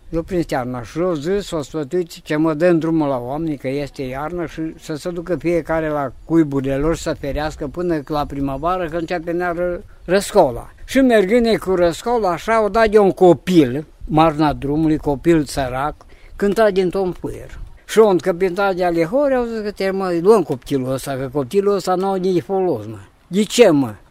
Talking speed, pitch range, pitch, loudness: 195 wpm, 150-190 Hz, 170 Hz, -18 LUFS